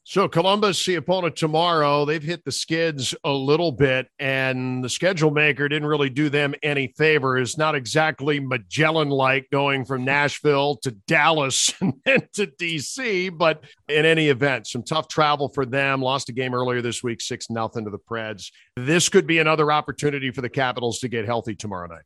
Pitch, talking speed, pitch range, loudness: 145 Hz, 190 wpm, 130-155 Hz, -21 LUFS